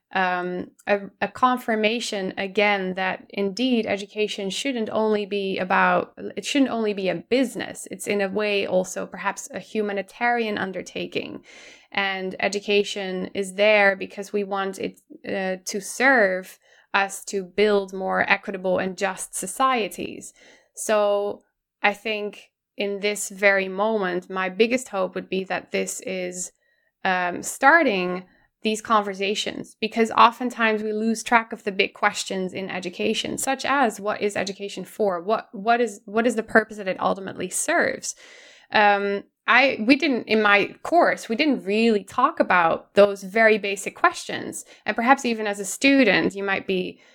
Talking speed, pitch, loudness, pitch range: 150 wpm, 205 Hz, -23 LUFS, 195-225 Hz